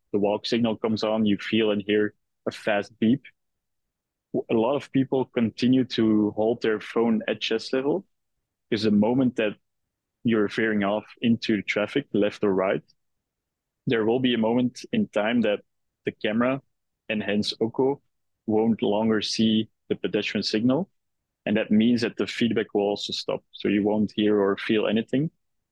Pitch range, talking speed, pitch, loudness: 105-120 Hz, 165 wpm, 110 Hz, -25 LUFS